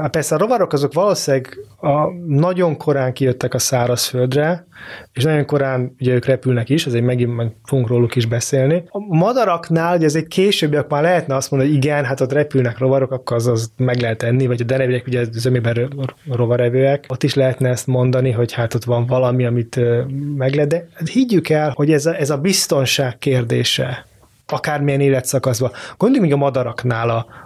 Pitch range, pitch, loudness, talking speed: 125-150 Hz, 135 Hz, -17 LUFS, 185 wpm